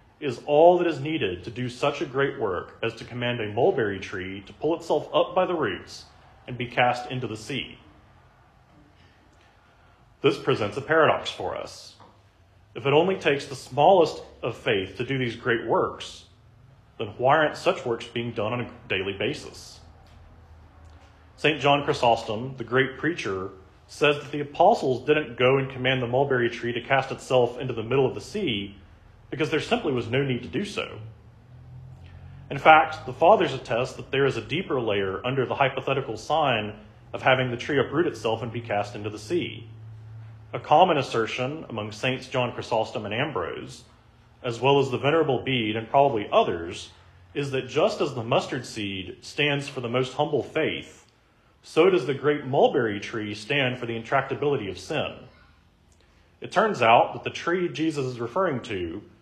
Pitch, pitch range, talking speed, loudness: 125 Hz, 110-140 Hz, 175 wpm, -25 LUFS